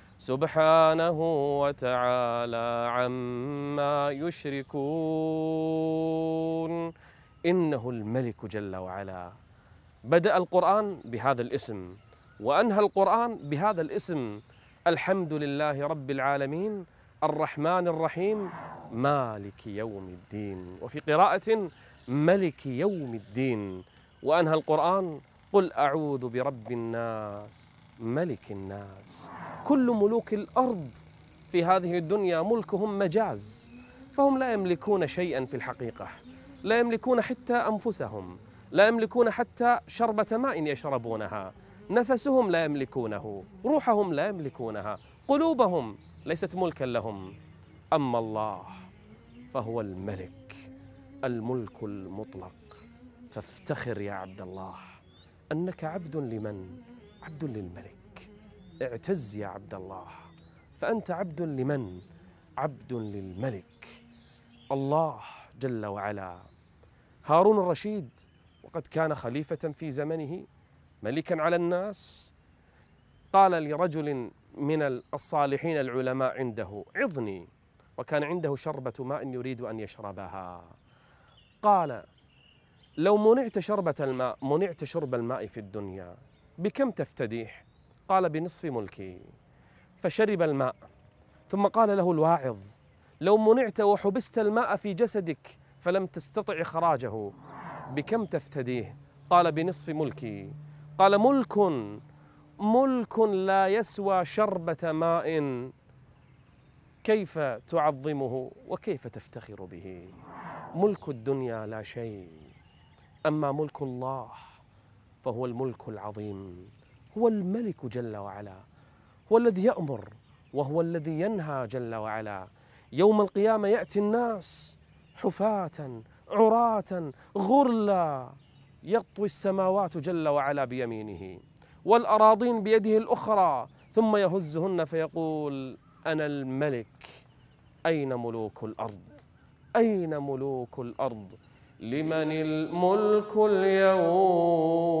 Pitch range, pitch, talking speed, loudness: 115-180 Hz, 140 Hz, 90 wpm, -28 LUFS